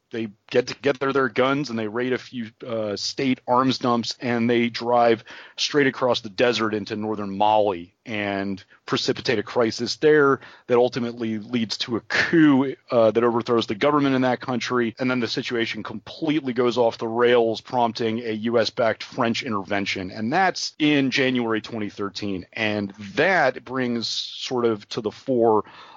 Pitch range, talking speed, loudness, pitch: 110-125 Hz, 165 wpm, -22 LUFS, 120 Hz